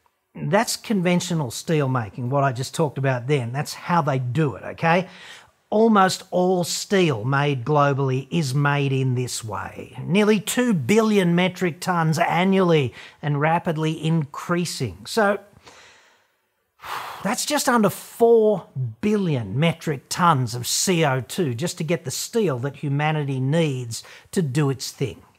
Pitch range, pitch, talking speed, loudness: 135-185 Hz, 160 Hz, 135 wpm, -22 LUFS